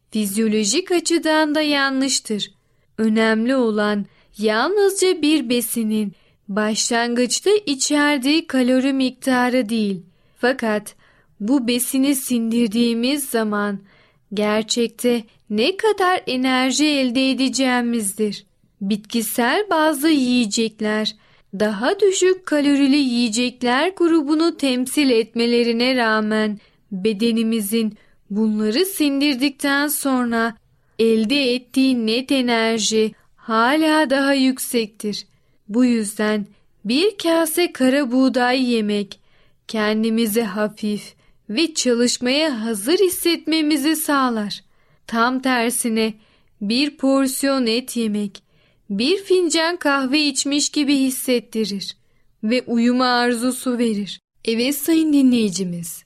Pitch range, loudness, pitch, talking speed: 215-280 Hz, -19 LUFS, 245 Hz, 85 wpm